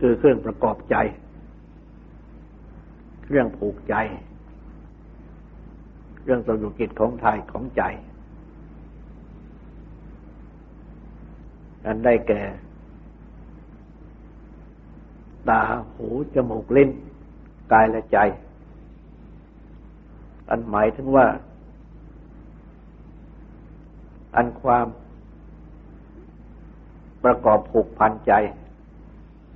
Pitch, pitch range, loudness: 110 Hz, 105-120 Hz, -21 LUFS